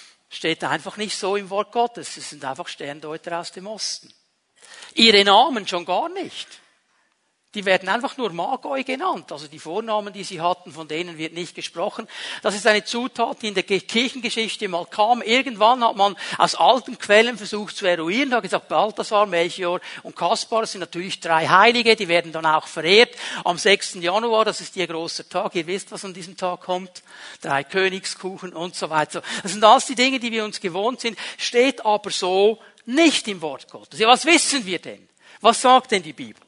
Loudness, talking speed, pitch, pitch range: -20 LUFS, 195 wpm, 200 Hz, 175-230 Hz